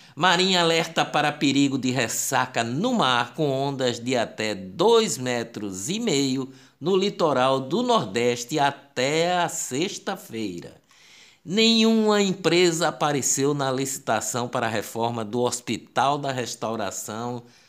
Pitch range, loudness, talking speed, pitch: 120-170 Hz, -23 LUFS, 120 wpm, 140 Hz